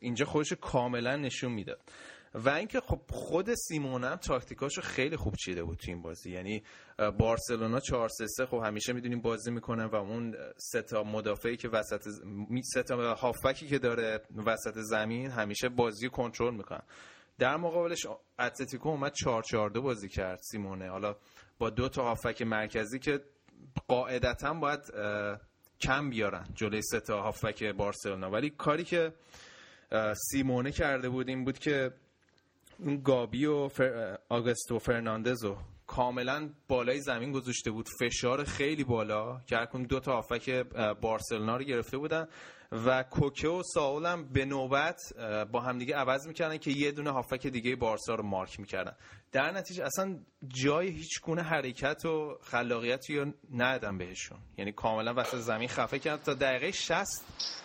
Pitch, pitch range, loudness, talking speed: 125 Hz, 110-140 Hz, -33 LUFS, 150 wpm